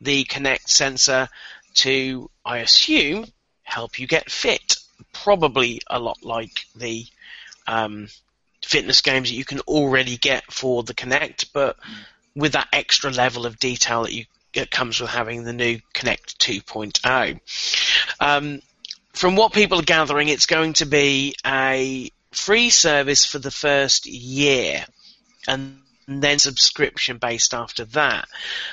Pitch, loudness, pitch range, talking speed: 135 Hz, -19 LUFS, 125-145 Hz, 135 wpm